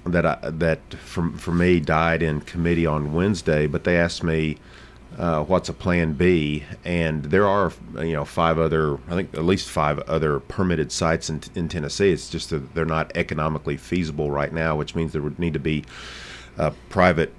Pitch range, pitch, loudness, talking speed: 75-85 Hz, 80 Hz, -23 LUFS, 190 wpm